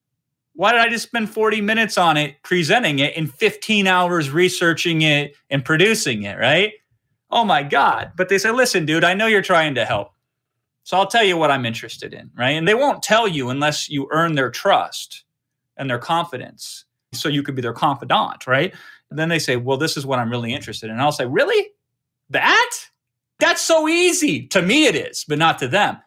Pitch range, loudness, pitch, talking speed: 135-215 Hz, -18 LUFS, 160 Hz, 210 wpm